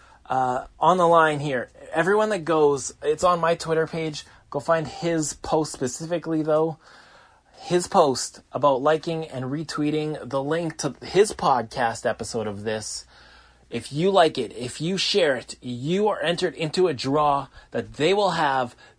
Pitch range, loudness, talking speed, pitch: 140-170 Hz, -23 LUFS, 160 wpm, 160 Hz